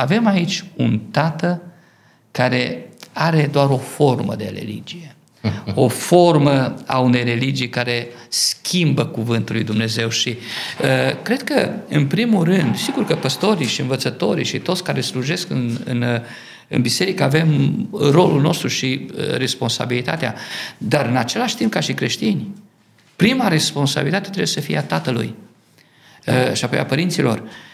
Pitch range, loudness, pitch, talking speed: 125-175 Hz, -18 LUFS, 145 Hz, 145 wpm